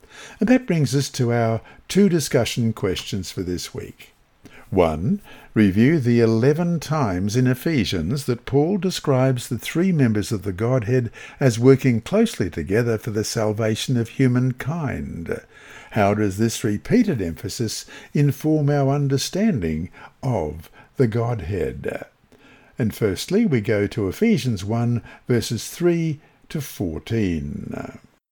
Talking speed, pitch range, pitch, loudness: 125 wpm, 110-145 Hz, 125 Hz, -21 LUFS